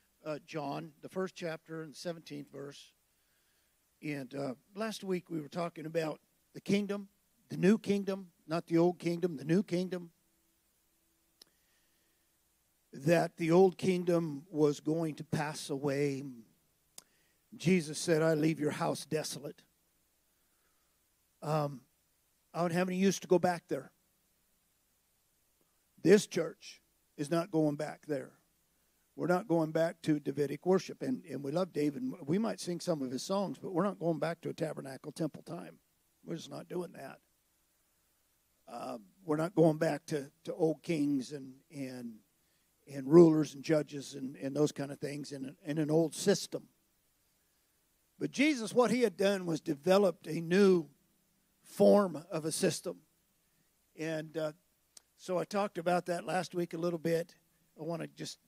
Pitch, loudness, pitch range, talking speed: 165 Hz, -33 LUFS, 150-180 Hz, 155 wpm